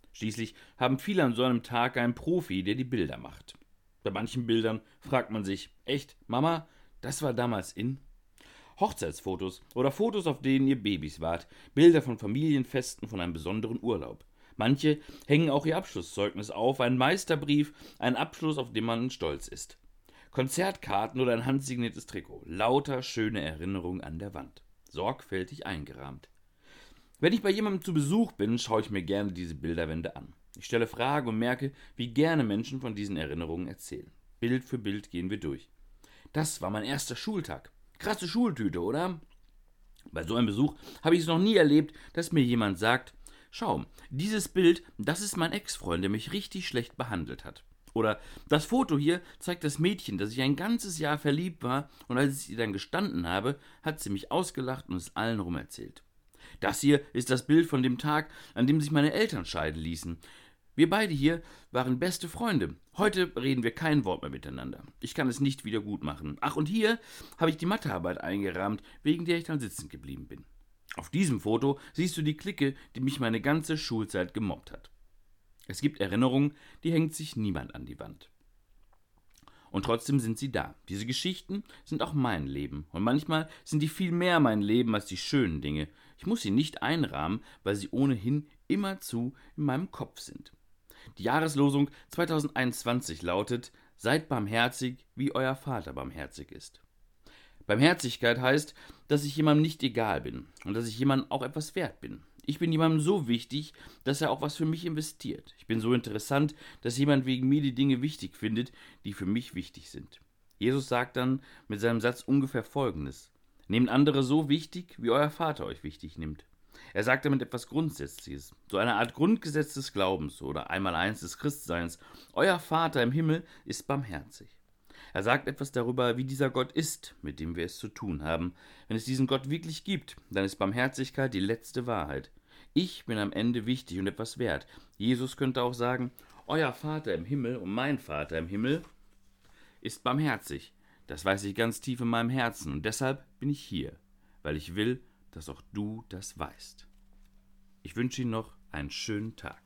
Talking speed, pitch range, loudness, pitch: 180 wpm, 100-150 Hz, -31 LUFS, 125 Hz